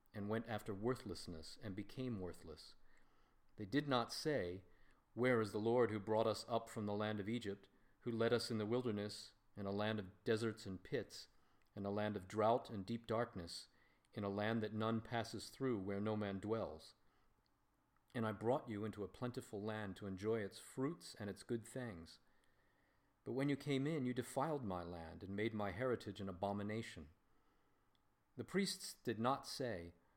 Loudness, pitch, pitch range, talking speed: -43 LUFS, 110 Hz, 100-120 Hz, 185 wpm